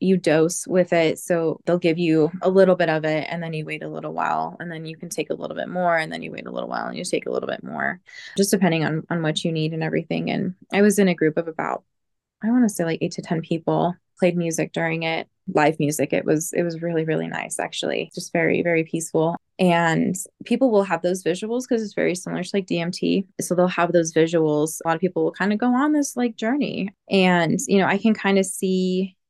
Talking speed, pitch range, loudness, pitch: 255 wpm, 160-195 Hz, -22 LUFS, 175 Hz